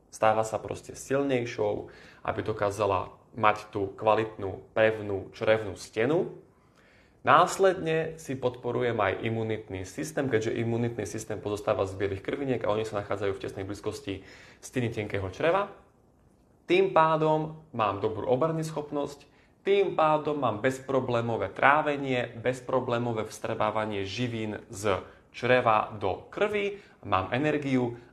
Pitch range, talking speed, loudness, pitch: 105-140 Hz, 115 wpm, -28 LUFS, 115 Hz